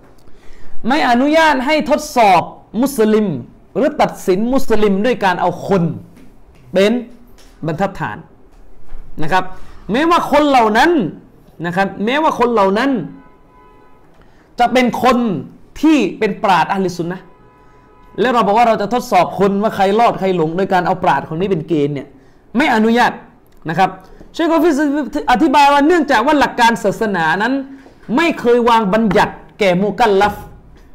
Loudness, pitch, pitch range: -14 LUFS, 215 Hz, 185-255 Hz